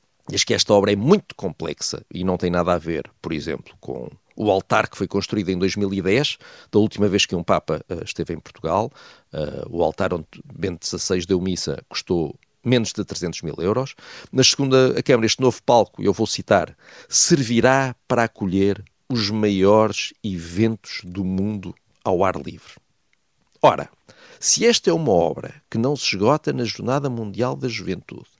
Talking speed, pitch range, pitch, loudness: 175 wpm, 95-125 Hz, 105 Hz, -21 LUFS